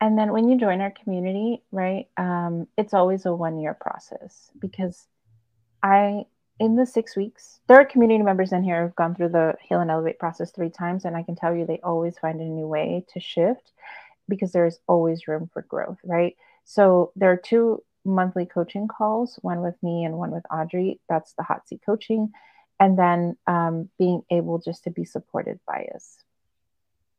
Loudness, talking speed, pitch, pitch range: -23 LUFS, 190 wpm, 175 Hz, 165-200 Hz